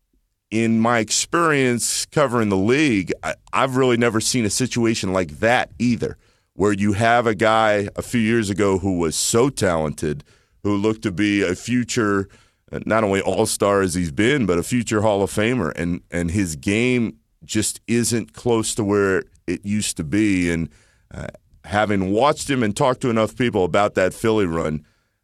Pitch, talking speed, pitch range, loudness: 105 Hz, 180 wpm, 95-115 Hz, -20 LUFS